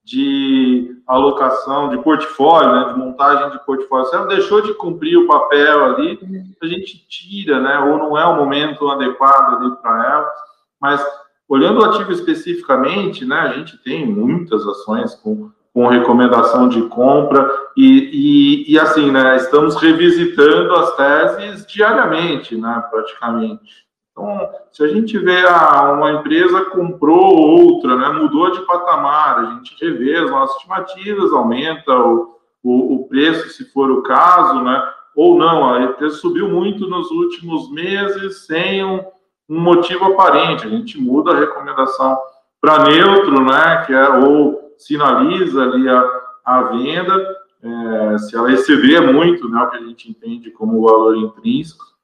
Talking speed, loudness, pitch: 150 wpm, -13 LUFS, 165 Hz